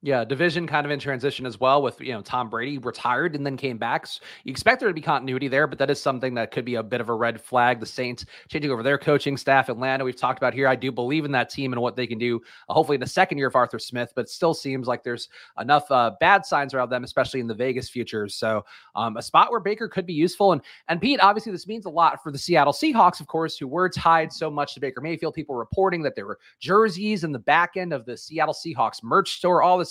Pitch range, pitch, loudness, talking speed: 125-165 Hz, 140 Hz, -23 LUFS, 275 wpm